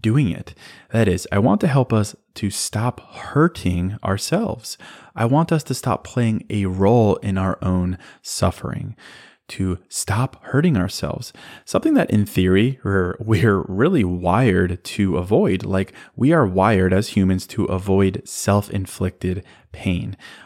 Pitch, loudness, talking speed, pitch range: 100 Hz, -20 LUFS, 145 wpm, 95-115 Hz